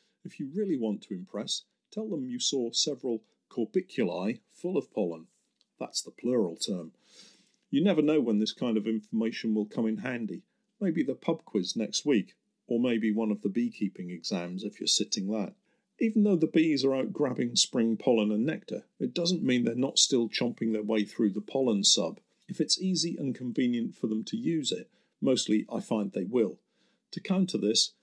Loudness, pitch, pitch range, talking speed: -29 LUFS, 120 Hz, 110-180 Hz, 195 wpm